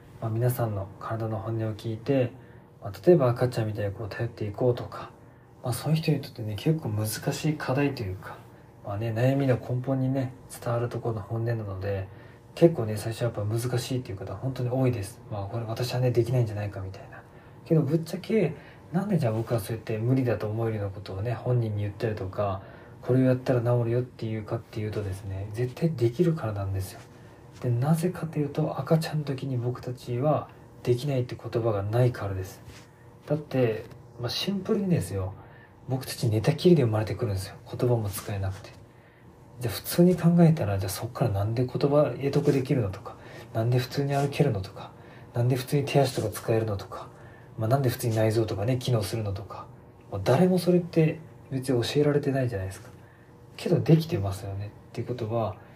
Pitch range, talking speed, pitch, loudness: 110-135 Hz, 420 characters per minute, 120 Hz, -27 LUFS